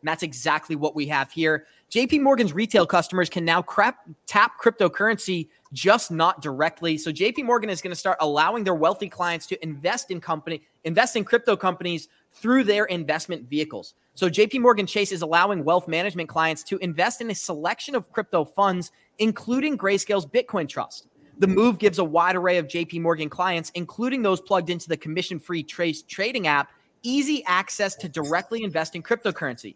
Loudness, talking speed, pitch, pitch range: -23 LUFS, 180 wpm, 180 Hz, 160-210 Hz